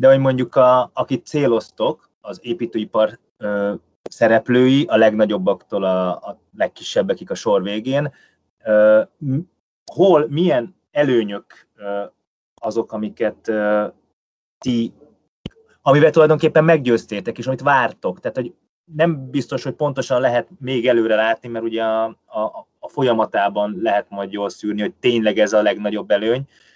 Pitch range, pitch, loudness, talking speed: 105-135 Hz, 115 Hz, -18 LUFS, 130 wpm